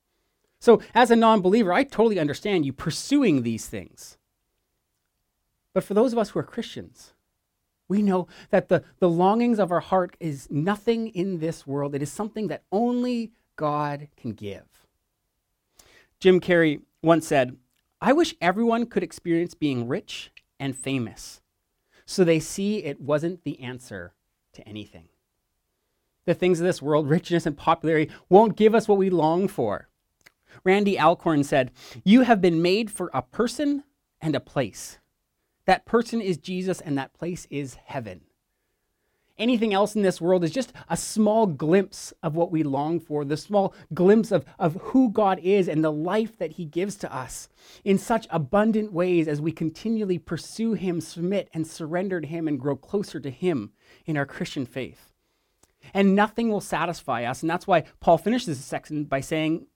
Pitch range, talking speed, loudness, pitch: 150-200 Hz, 170 wpm, -24 LUFS, 175 Hz